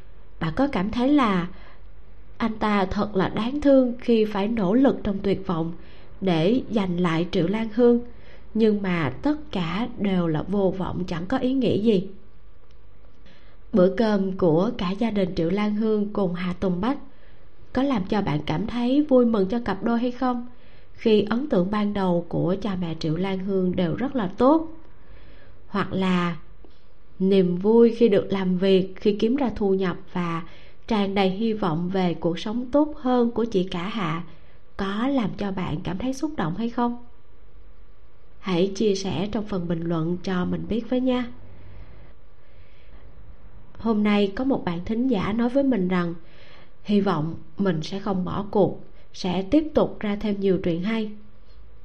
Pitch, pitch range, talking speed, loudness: 195 Hz, 175-230 Hz, 175 wpm, -24 LUFS